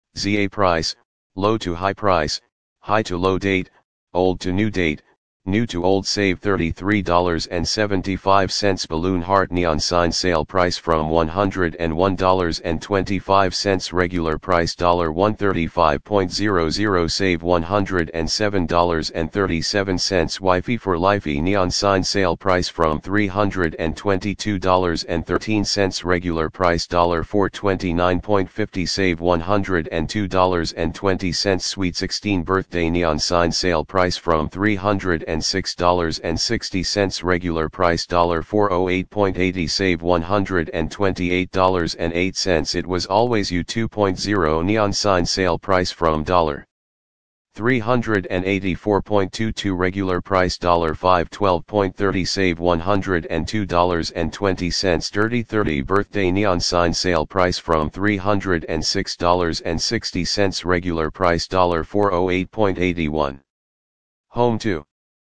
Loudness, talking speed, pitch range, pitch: -20 LUFS, 85 wpm, 85-100 Hz, 90 Hz